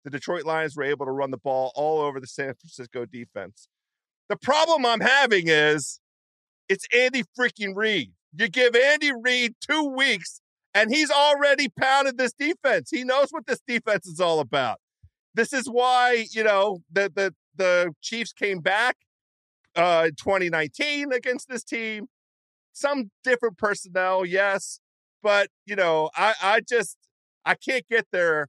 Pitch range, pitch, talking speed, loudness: 165-250 Hz, 205 Hz, 160 wpm, -23 LUFS